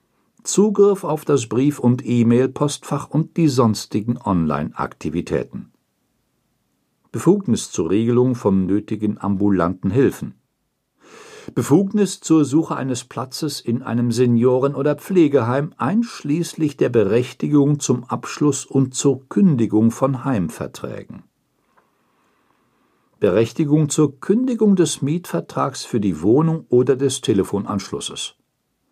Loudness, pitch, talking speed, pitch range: -19 LUFS, 135 Hz, 100 wpm, 120-155 Hz